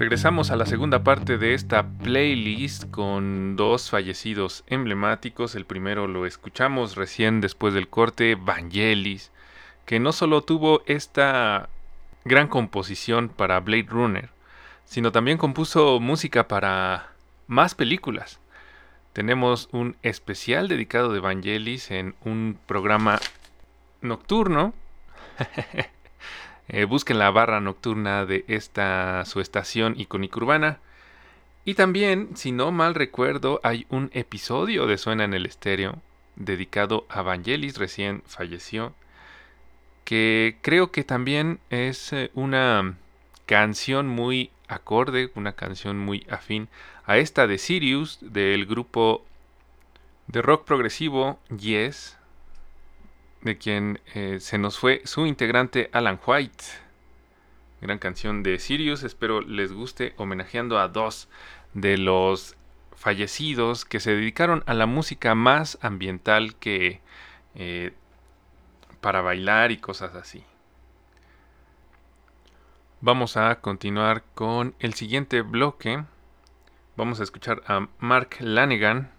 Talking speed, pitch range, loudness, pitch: 115 wpm, 95-125 Hz, -24 LUFS, 110 Hz